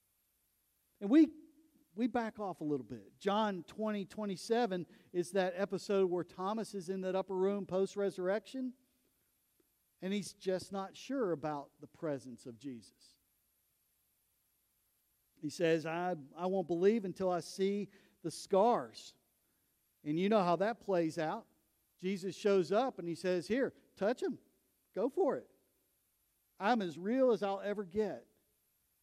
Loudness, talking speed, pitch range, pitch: -36 LUFS, 145 wpm, 165-205 Hz, 190 Hz